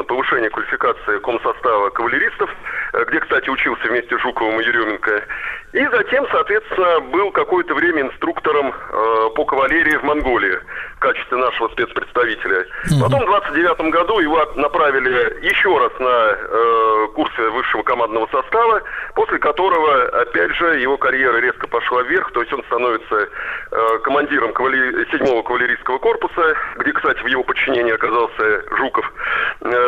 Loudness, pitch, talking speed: -17 LUFS, 140 Hz, 135 wpm